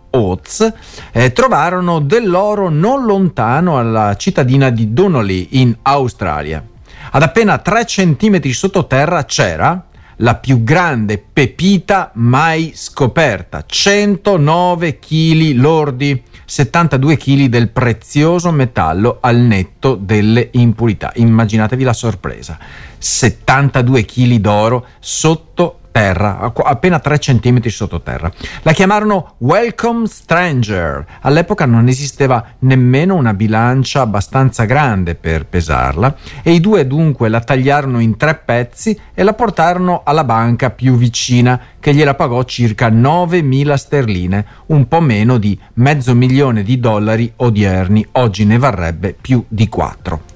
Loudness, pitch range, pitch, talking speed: -12 LUFS, 110-160 Hz, 130 Hz, 115 wpm